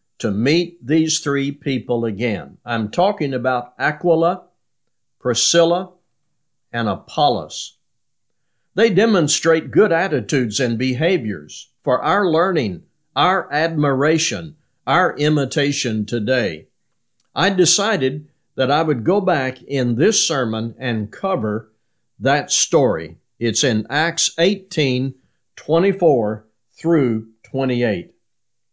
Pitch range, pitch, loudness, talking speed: 120-170 Hz, 140 Hz, -18 LUFS, 100 wpm